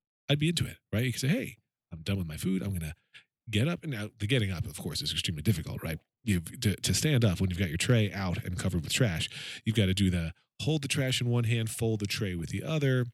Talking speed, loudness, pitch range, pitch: 285 wpm, -30 LUFS, 95-125 Hz, 110 Hz